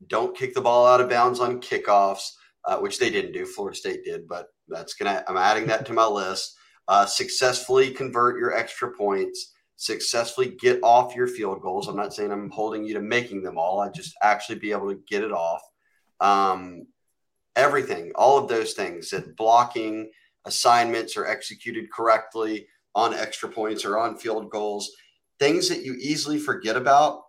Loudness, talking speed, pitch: -23 LUFS, 185 wpm, 125 Hz